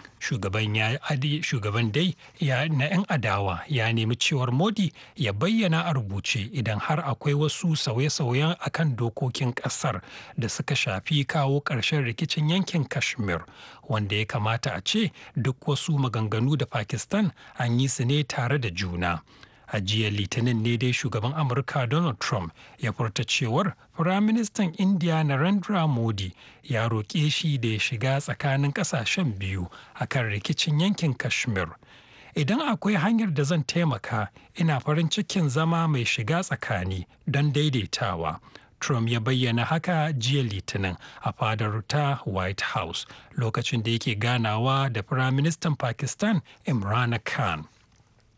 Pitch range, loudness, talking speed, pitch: 115-155 Hz, -26 LUFS, 140 wpm, 135 Hz